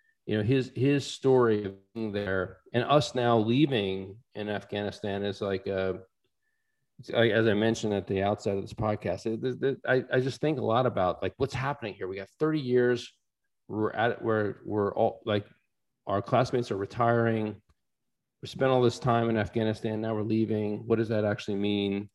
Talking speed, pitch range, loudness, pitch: 190 wpm, 100-125 Hz, -28 LUFS, 110 Hz